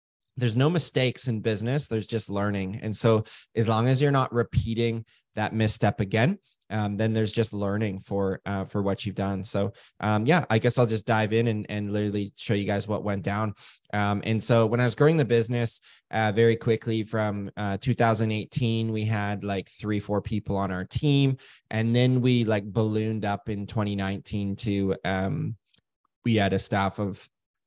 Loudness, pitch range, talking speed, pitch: -26 LUFS, 100-115 Hz, 190 wpm, 110 Hz